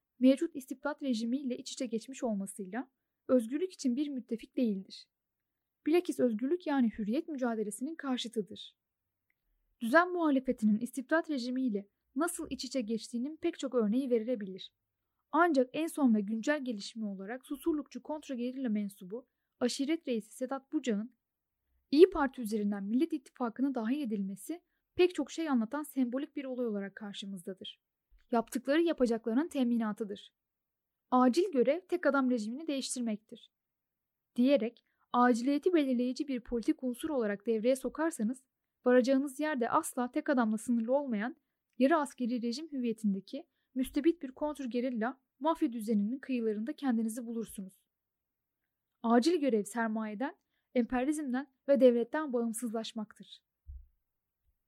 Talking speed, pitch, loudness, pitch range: 115 wpm, 255 Hz, -33 LUFS, 230-285 Hz